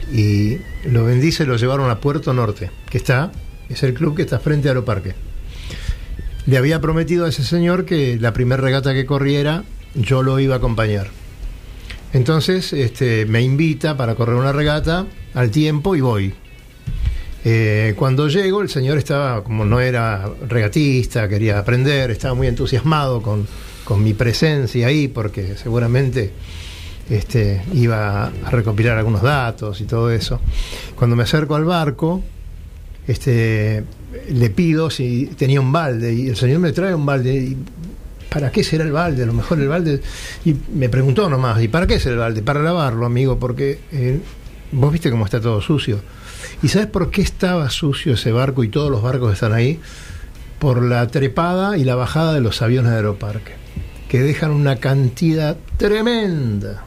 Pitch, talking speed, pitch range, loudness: 130 Hz, 170 wpm, 115-150 Hz, -18 LUFS